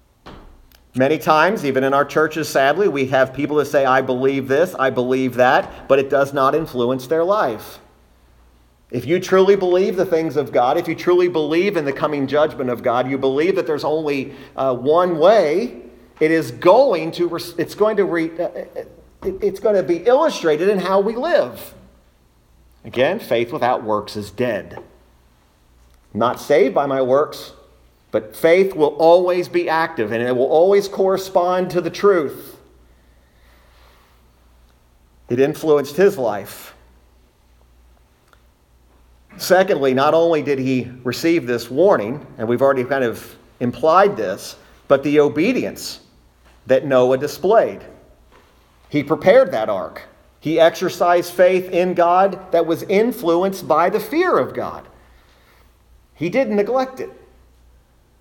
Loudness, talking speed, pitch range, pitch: -17 LUFS, 140 wpm, 105-175 Hz, 140 Hz